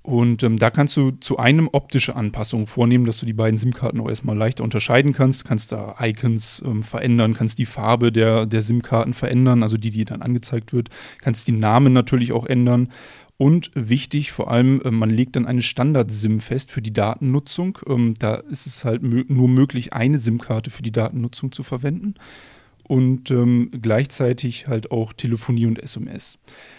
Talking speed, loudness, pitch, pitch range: 180 wpm, -20 LUFS, 120 Hz, 115-130 Hz